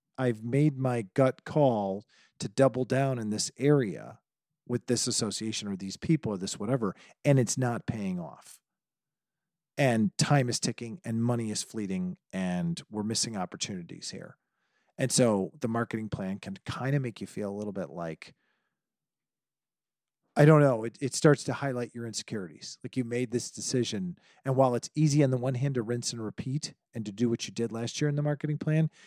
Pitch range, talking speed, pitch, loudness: 115-145 Hz, 190 wpm, 125 Hz, -29 LUFS